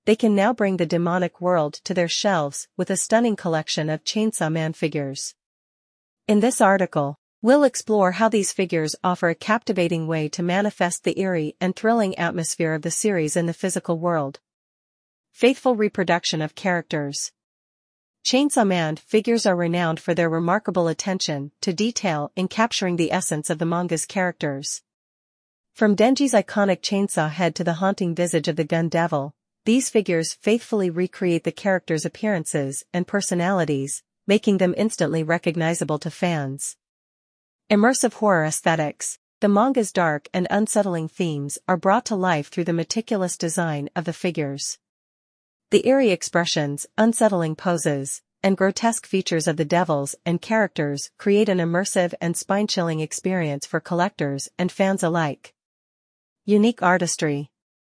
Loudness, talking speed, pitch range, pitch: -22 LUFS, 145 wpm, 160-205 Hz, 175 Hz